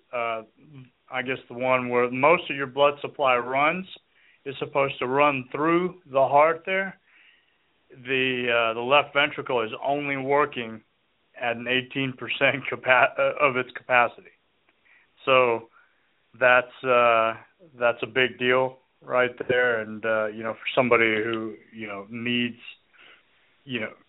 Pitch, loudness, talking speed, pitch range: 130 Hz, -23 LUFS, 140 wpm, 120-140 Hz